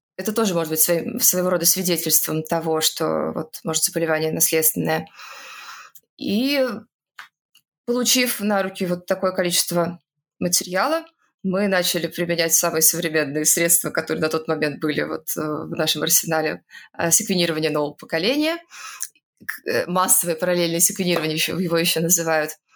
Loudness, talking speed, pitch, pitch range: -20 LUFS, 120 wpm, 170 Hz, 160-190 Hz